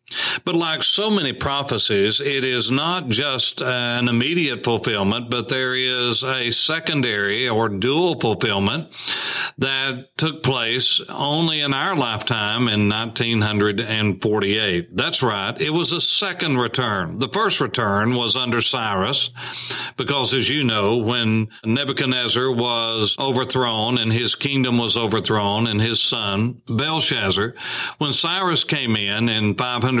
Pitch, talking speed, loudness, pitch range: 125 Hz, 130 wpm, -19 LUFS, 110-135 Hz